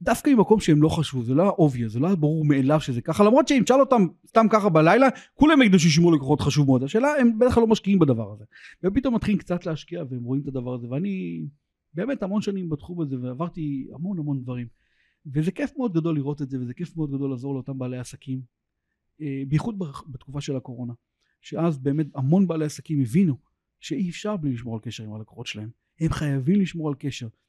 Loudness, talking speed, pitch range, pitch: -23 LUFS, 195 wpm, 130-190 Hz, 150 Hz